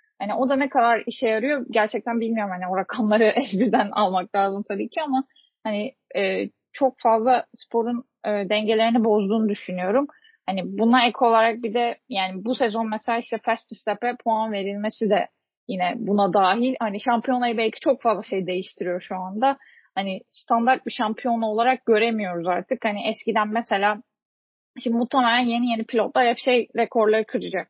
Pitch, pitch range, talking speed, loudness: 225 Hz, 210-245 Hz, 160 wpm, -23 LUFS